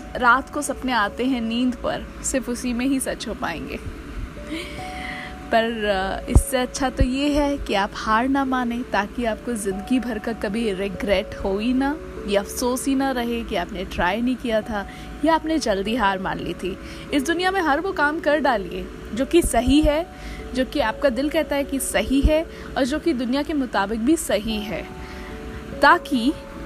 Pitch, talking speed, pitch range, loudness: 255 Hz, 190 wpm, 225-290 Hz, -22 LUFS